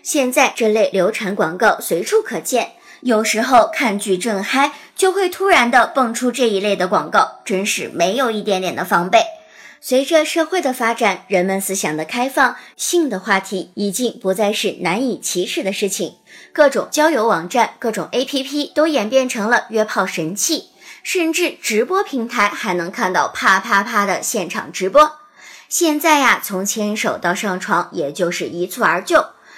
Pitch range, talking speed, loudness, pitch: 195-285 Hz, 260 characters per minute, -17 LUFS, 225 Hz